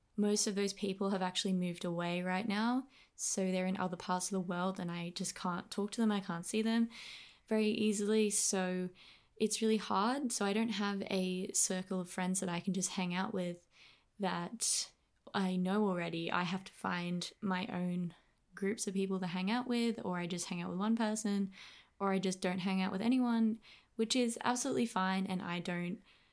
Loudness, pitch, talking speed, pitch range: -36 LUFS, 190 Hz, 205 wpm, 180-215 Hz